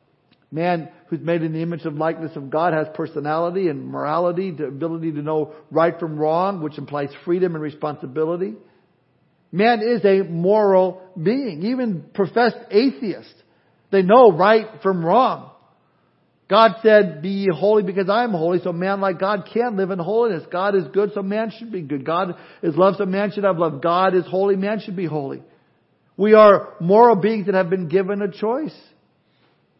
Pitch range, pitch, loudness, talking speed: 165-205 Hz, 185 Hz, -19 LUFS, 175 wpm